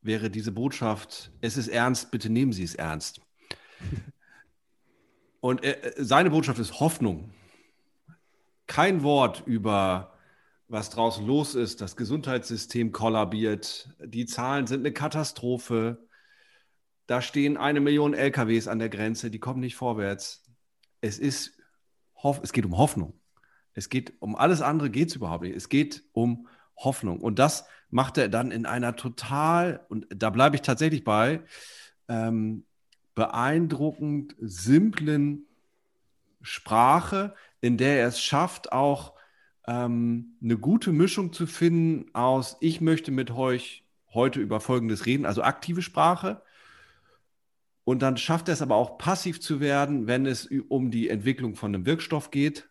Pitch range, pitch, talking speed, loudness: 115-145 Hz, 125 Hz, 140 wpm, -26 LUFS